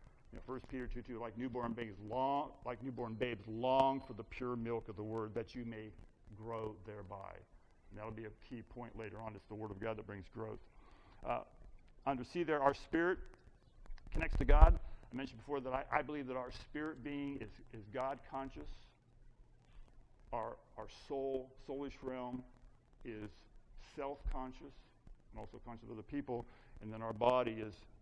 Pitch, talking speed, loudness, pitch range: 120 Hz, 180 wpm, -41 LUFS, 110-130 Hz